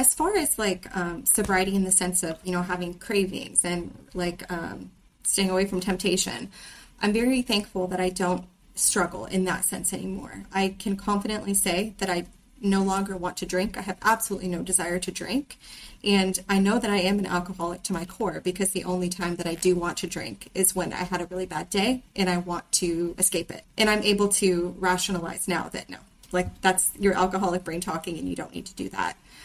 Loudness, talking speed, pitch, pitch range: -26 LUFS, 215 wpm, 185 Hz, 180-200 Hz